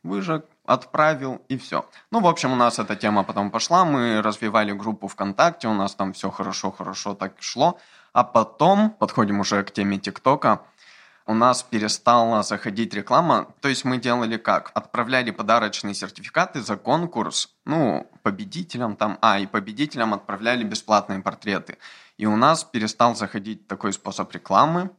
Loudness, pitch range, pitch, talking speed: -22 LUFS, 100-125 Hz, 110 Hz, 150 wpm